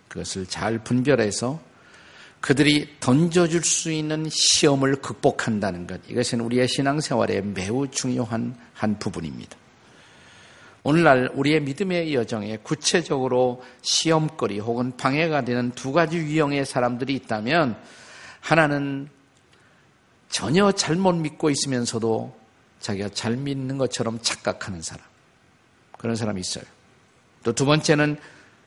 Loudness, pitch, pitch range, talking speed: -23 LUFS, 130 Hz, 115-150 Hz, 275 characters per minute